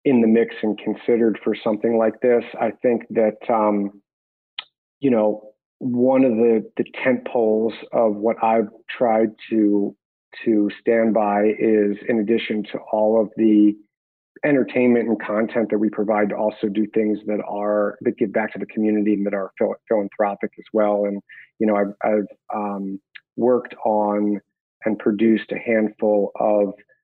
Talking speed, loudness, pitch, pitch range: 160 wpm, -21 LUFS, 110 Hz, 105-115 Hz